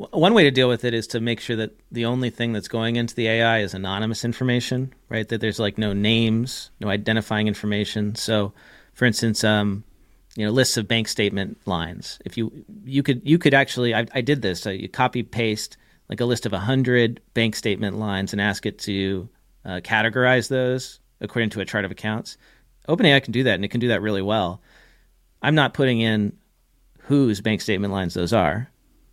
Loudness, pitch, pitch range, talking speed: -22 LUFS, 115 Hz, 105-125 Hz, 205 wpm